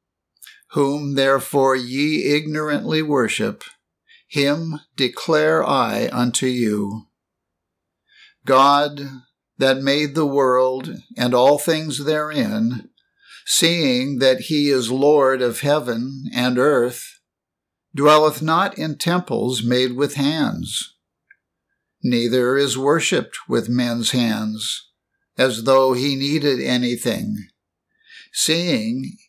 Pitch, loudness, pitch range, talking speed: 140 Hz, -19 LUFS, 125-155 Hz, 95 wpm